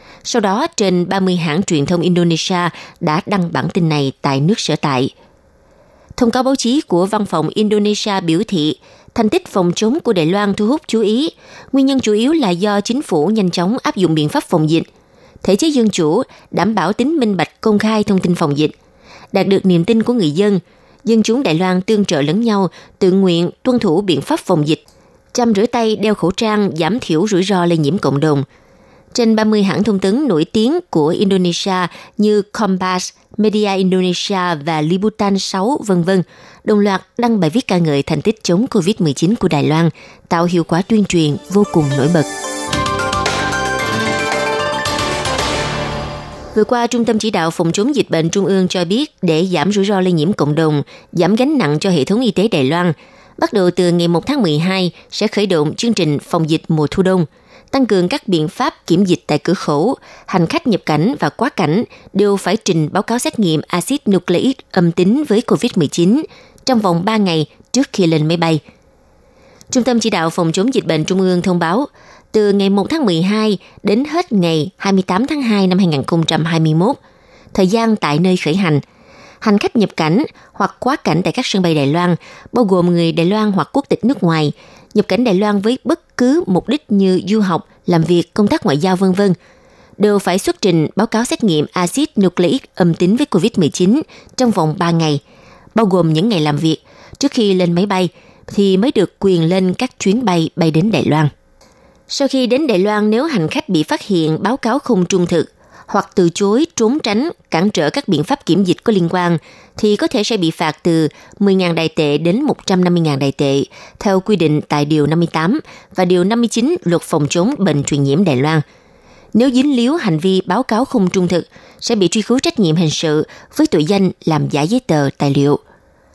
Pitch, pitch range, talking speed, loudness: 190 Hz, 165-220 Hz, 210 wpm, -15 LUFS